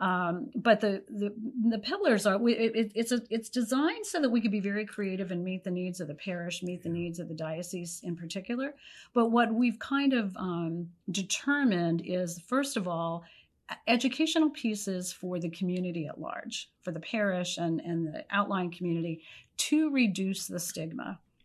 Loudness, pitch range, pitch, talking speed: -31 LUFS, 175-235 Hz, 195 Hz, 180 wpm